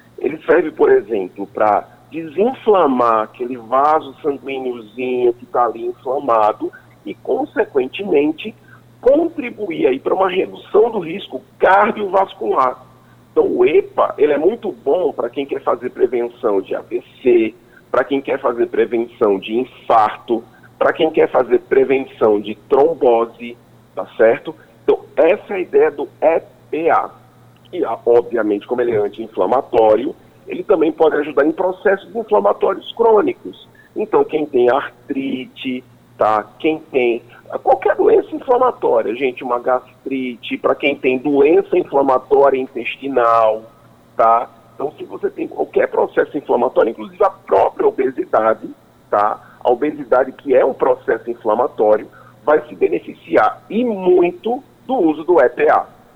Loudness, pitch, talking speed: -17 LUFS, 240 Hz, 130 wpm